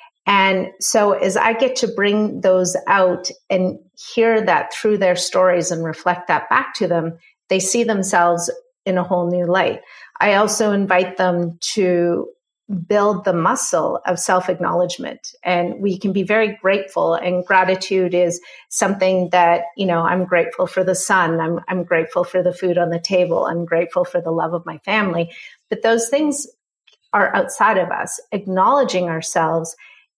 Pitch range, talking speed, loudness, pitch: 175-210 Hz, 165 wpm, -18 LUFS, 185 Hz